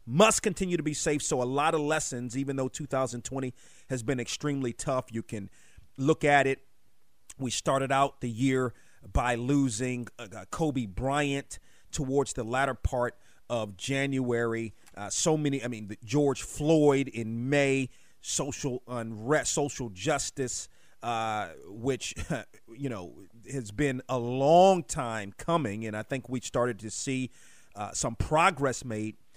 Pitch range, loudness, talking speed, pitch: 115-140 Hz, -29 LUFS, 145 wpm, 130 Hz